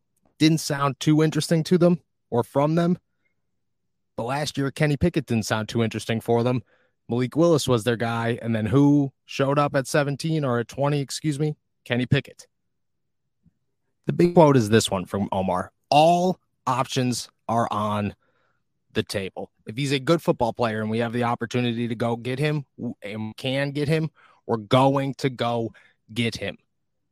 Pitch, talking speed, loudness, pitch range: 130 Hz, 175 wpm, -23 LUFS, 115-150 Hz